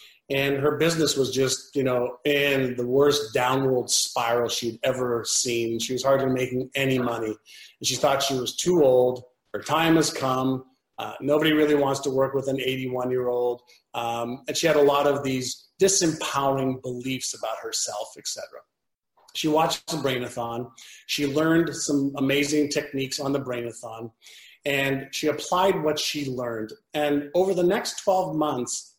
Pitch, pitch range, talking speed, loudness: 135 Hz, 125-150 Hz, 160 wpm, -24 LUFS